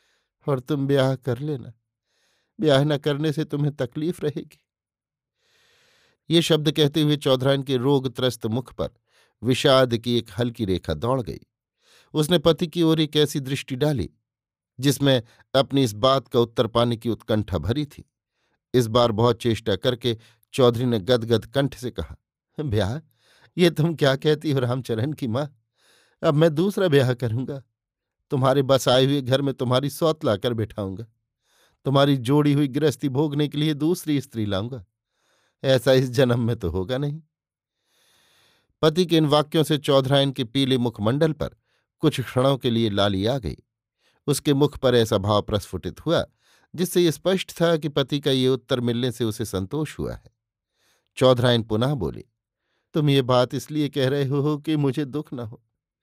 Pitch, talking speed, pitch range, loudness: 130 Hz, 165 wpm, 120-150 Hz, -22 LUFS